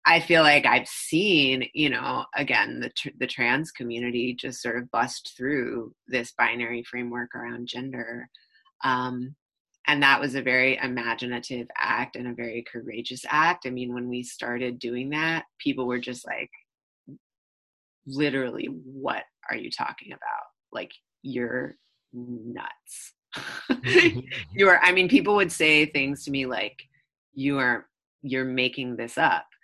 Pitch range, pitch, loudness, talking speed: 120-140 Hz, 125 Hz, -24 LUFS, 150 wpm